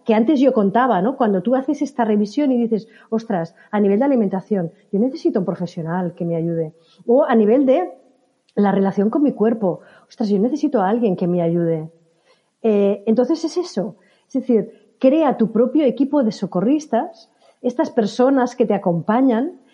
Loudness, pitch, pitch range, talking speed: -19 LUFS, 225 Hz, 195-260 Hz, 175 wpm